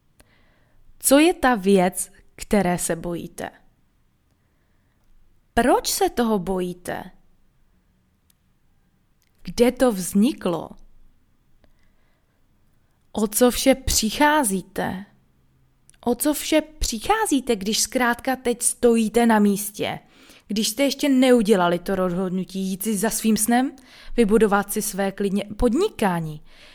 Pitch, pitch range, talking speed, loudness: 220 Hz, 185-250 Hz, 100 wpm, -21 LUFS